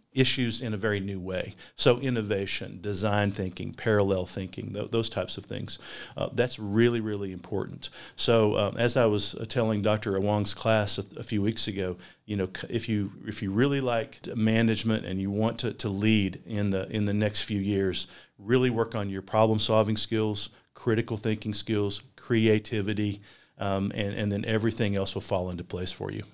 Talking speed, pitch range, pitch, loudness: 185 wpm, 100-115 Hz, 105 Hz, -28 LUFS